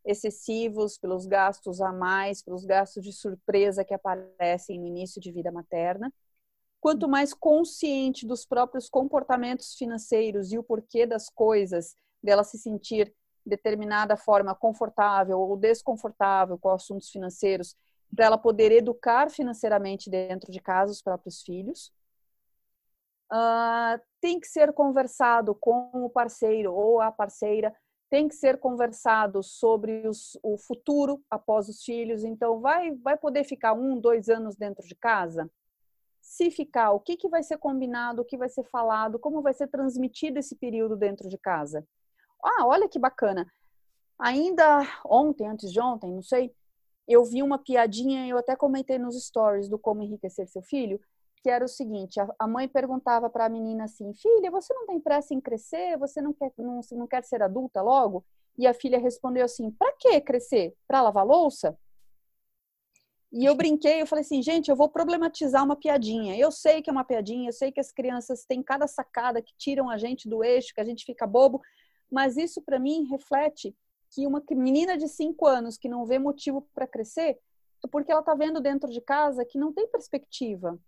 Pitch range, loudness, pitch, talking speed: 210-280 Hz, -26 LUFS, 240 Hz, 175 wpm